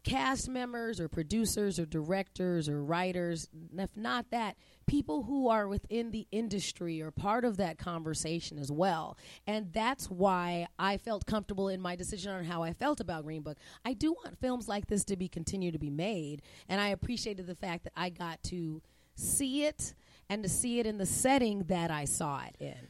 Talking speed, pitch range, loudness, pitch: 195 wpm, 165-220 Hz, -34 LUFS, 190 Hz